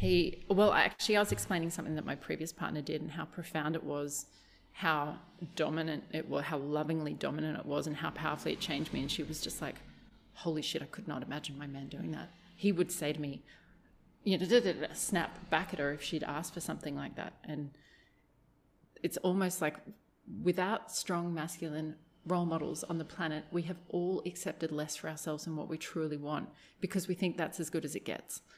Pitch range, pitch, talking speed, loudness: 150-180 Hz, 160 Hz, 215 wpm, -36 LUFS